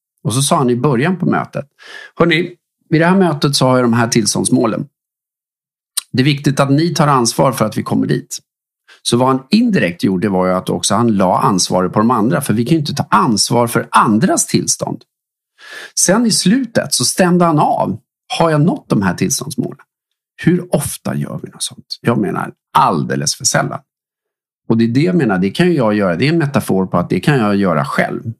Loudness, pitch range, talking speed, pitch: -14 LUFS, 115-175 Hz, 210 wpm, 140 Hz